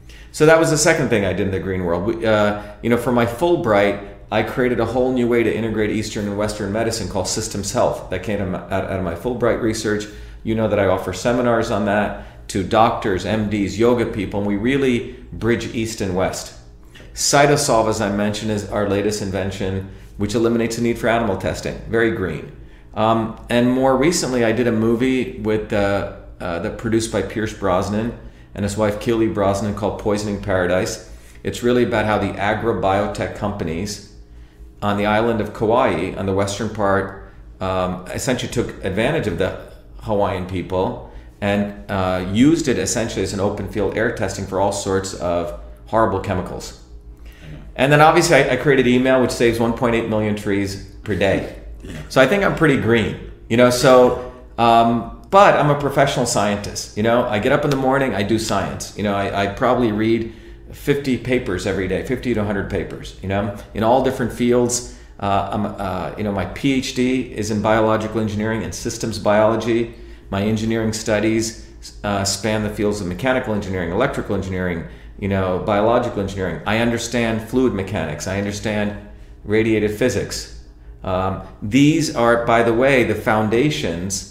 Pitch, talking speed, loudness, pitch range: 105 Hz, 175 wpm, -19 LUFS, 95-115 Hz